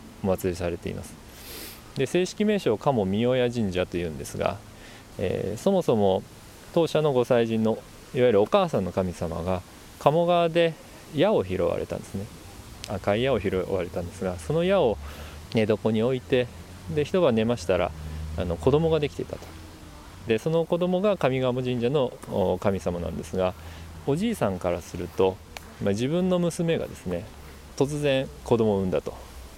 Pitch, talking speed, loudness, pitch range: 100 Hz, 310 characters per minute, -26 LUFS, 85-135 Hz